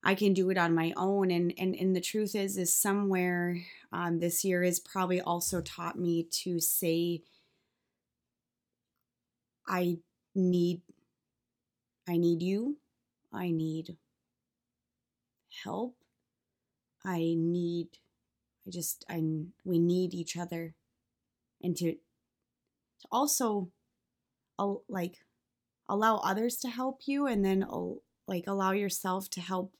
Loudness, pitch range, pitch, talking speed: -32 LUFS, 170-195 Hz, 180 Hz, 125 wpm